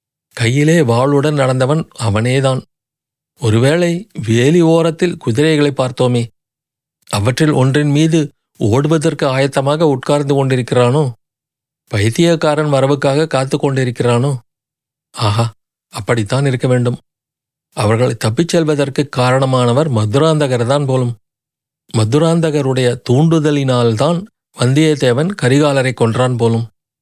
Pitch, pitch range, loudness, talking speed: 135 Hz, 125-150 Hz, -14 LUFS, 80 wpm